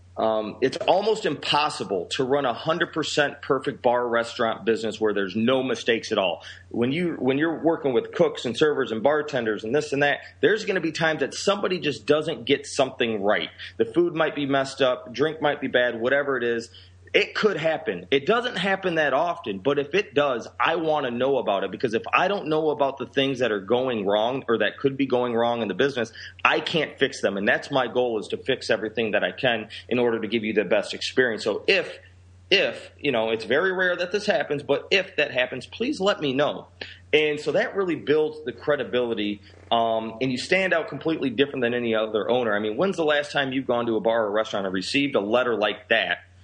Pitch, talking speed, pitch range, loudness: 135 Hz, 225 wpm, 115-155 Hz, -24 LUFS